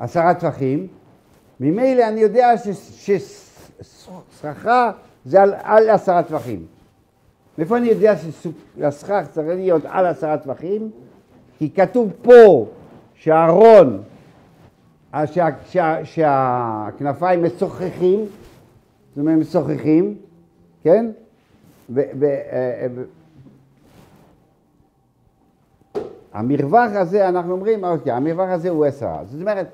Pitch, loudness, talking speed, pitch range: 175 Hz, -17 LUFS, 80 wpm, 150-205 Hz